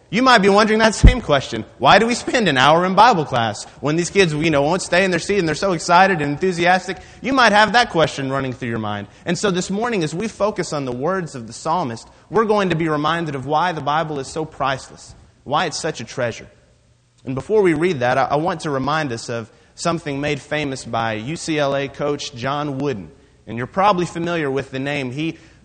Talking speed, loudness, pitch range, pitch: 230 wpm, -18 LUFS, 135-185 Hz, 155 Hz